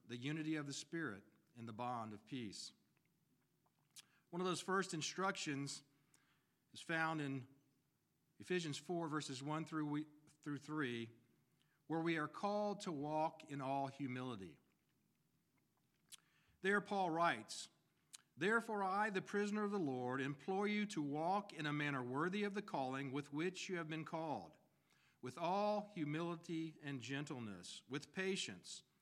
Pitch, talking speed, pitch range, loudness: 155 Hz, 140 wpm, 140-180 Hz, -43 LUFS